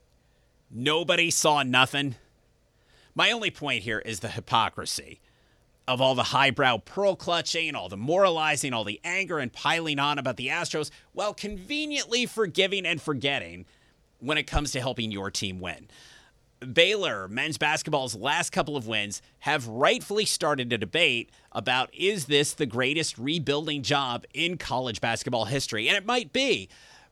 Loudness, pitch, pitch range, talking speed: -26 LUFS, 145 Hz, 125-170 Hz, 150 wpm